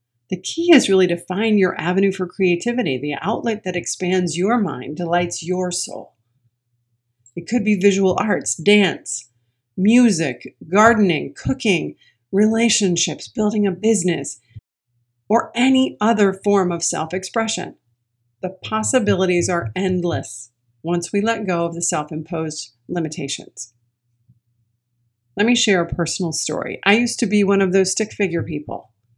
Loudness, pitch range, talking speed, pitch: -19 LUFS, 125-205 Hz, 140 wpm, 180 Hz